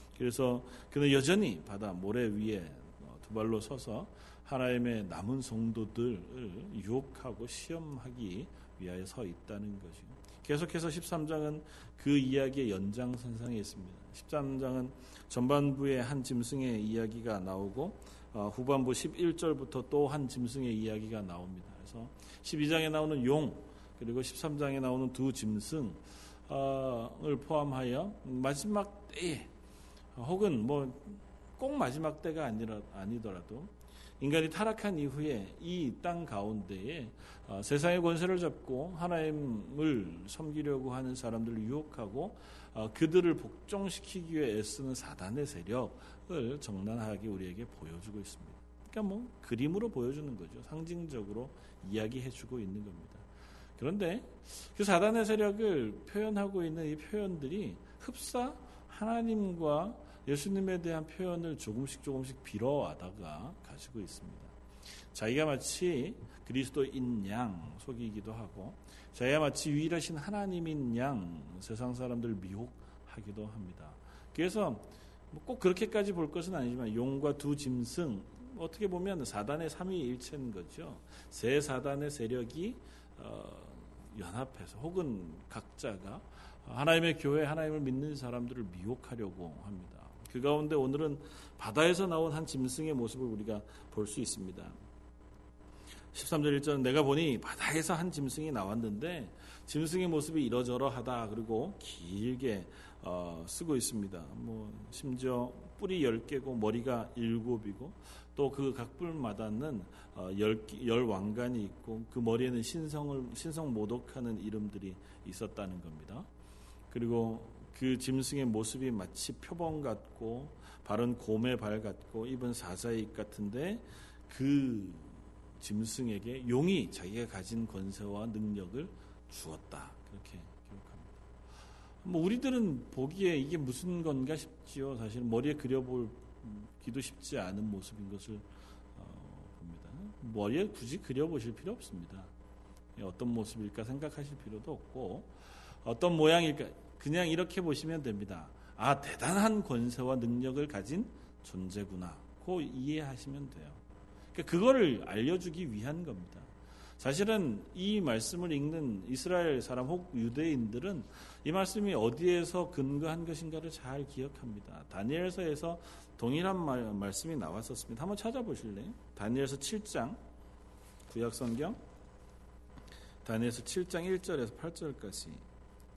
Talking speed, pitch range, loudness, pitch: 285 characters per minute, 105-155 Hz, -36 LUFS, 125 Hz